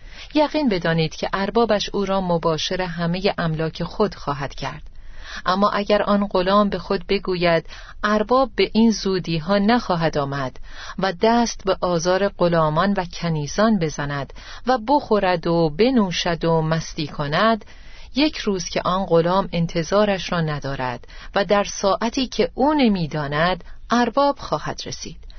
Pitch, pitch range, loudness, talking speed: 190 Hz, 165-210 Hz, -21 LUFS, 135 wpm